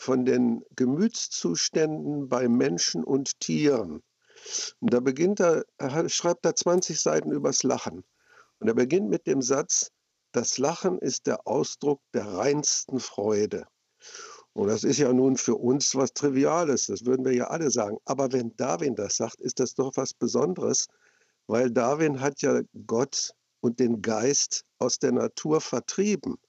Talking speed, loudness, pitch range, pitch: 155 wpm, -26 LUFS, 125-165 Hz, 135 Hz